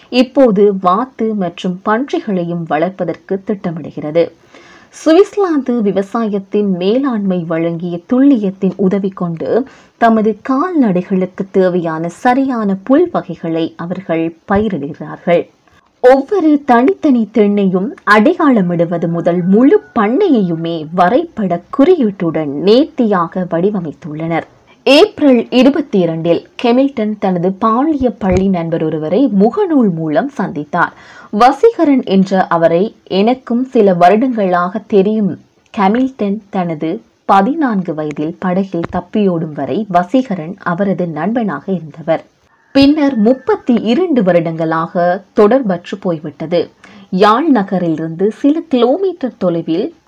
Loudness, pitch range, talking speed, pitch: -13 LUFS, 175-245 Hz, 85 wpm, 200 Hz